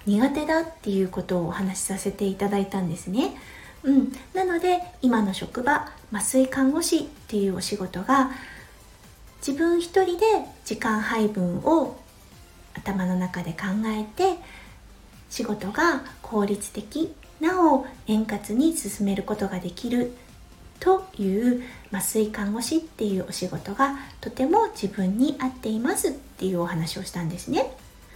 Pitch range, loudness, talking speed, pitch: 195-290 Hz, -25 LUFS, 275 characters per minute, 220 Hz